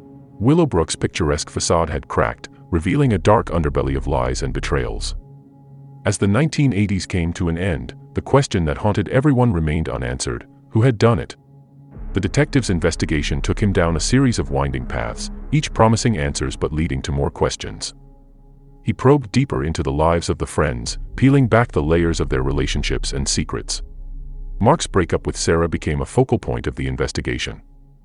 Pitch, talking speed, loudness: 95 Hz, 170 wpm, -20 LUFS